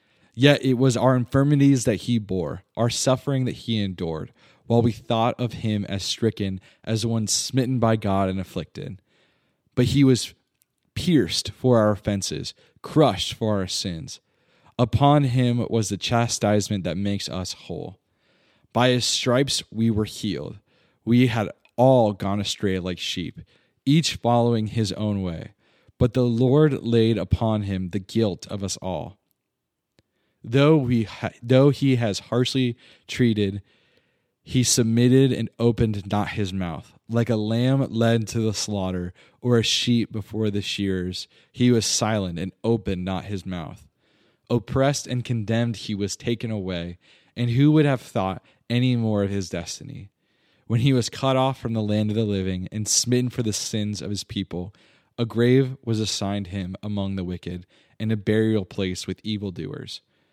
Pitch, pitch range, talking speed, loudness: 110 Hz, 100-125 Hz, 160 wpm, -23 LUFS